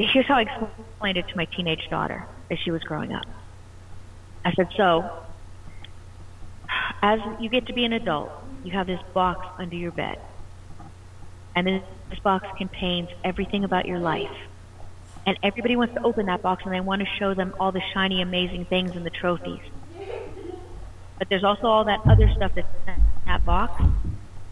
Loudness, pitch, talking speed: -25 LUFS, 175 Hz, 175 wpm